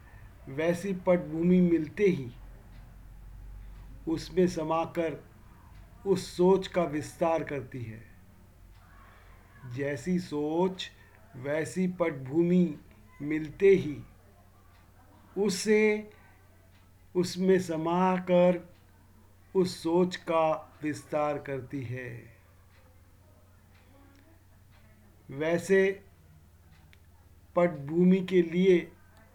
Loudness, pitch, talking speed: -28 LUFS, 135 Hz, 65 wpm